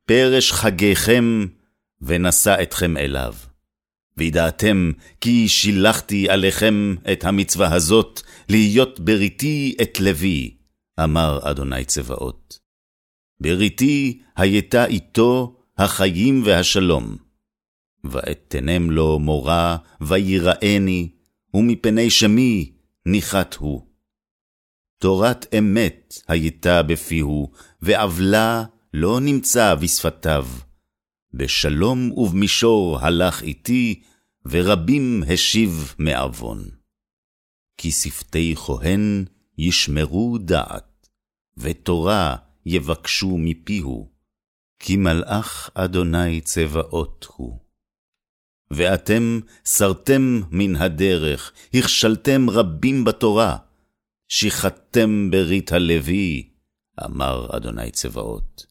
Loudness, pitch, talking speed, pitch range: -19 LUFS, 90 Hz, 75 wpm, 80-110 Hz